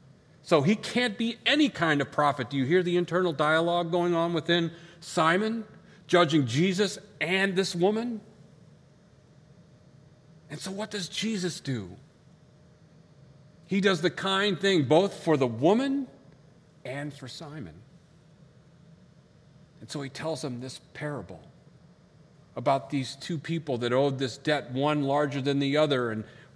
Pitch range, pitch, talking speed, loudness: 145-175 Hz, 155 Hz, 140 wpm, -27 LUFS